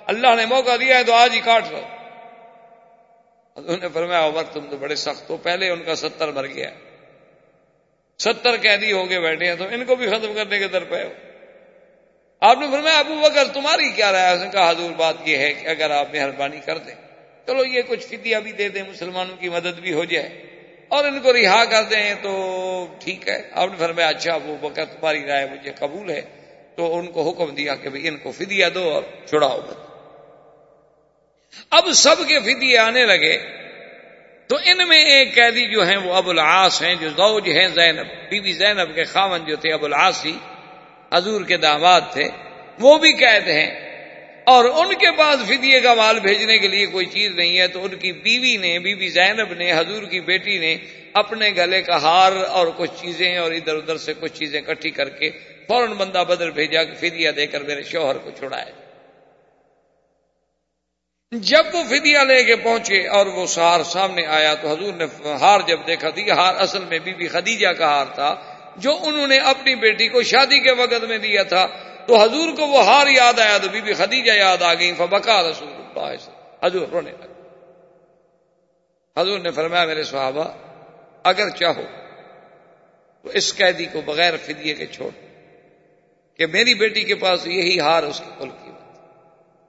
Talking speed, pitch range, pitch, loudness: 190 wpm, 165-235 Hz, 185 Hz, -17 LUFS